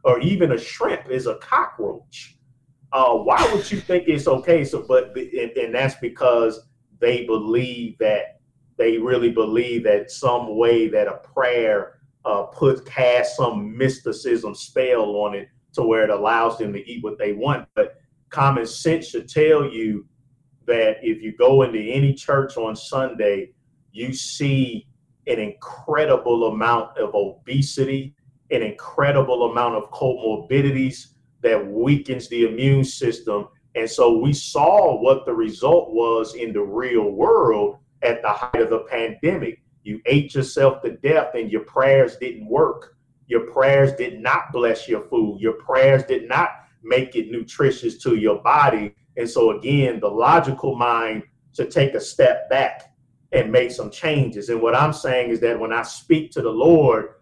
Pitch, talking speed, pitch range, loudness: 130 Hz, 165 wpm, 115-160 Hz, -20 LUFS